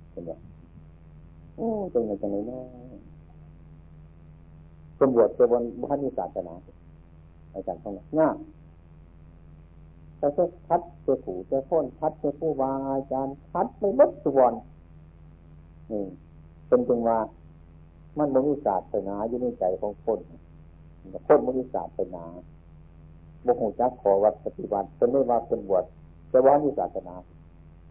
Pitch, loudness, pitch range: 85 Hz, -26 LUFS, 80-125 Hz